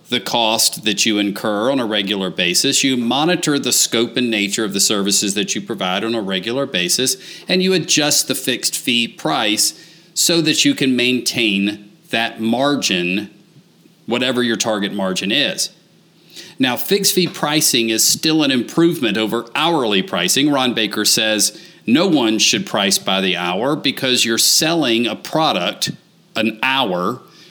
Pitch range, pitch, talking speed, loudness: 105-145 Hz, 115 Hz, 155 wpm, -16 LUFS